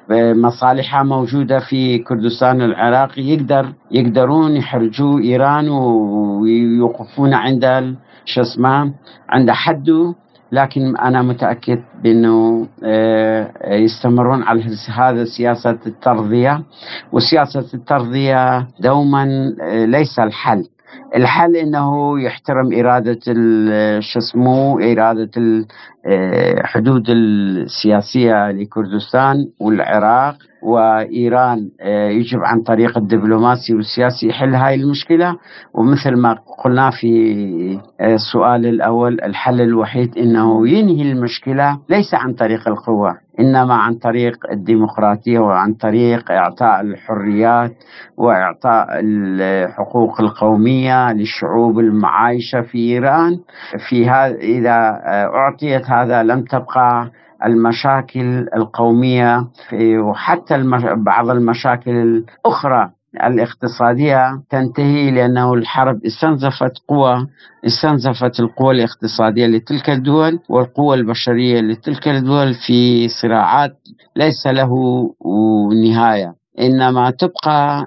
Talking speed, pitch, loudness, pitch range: 90 wpm, 120 Hz, -14 LUFS, 115-135 Hz